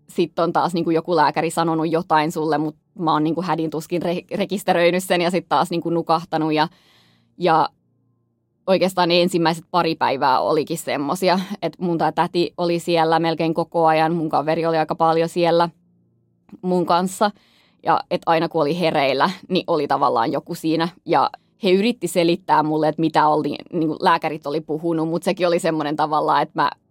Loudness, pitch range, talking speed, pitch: -20 LUFS, 155-175 Hz, 175 wpm, 165 Hz